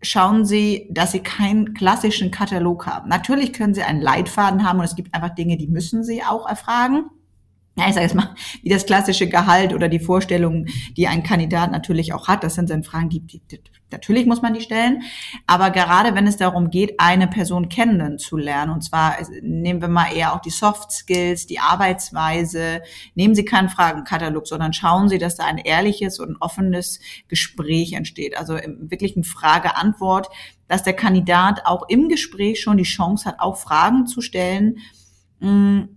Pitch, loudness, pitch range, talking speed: 180 Hz, -18 LUFS, 165-205 Hz, 185 wpm